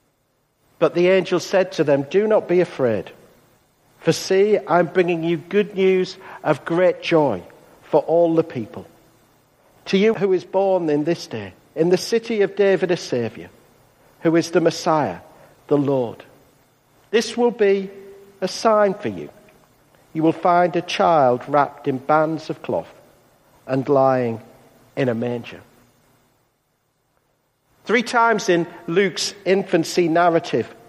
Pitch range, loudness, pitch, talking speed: 135-190 Hz, -19 LUFS, 165 Hz, 140 wpm